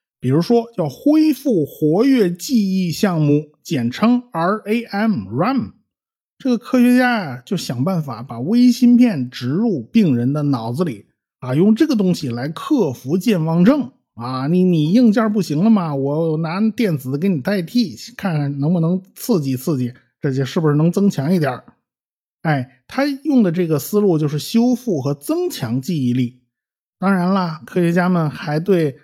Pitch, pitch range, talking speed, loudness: 175 Hz, 145-220 Hz, 250 characters per minute, -18 LUFS